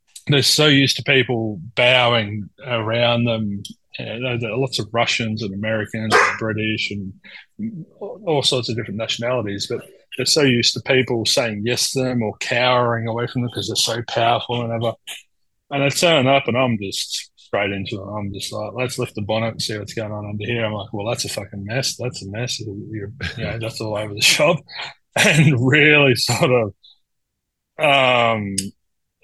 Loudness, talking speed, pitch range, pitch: -19 LUFS, 190 wpm, 105-125 Hz, 115 Hz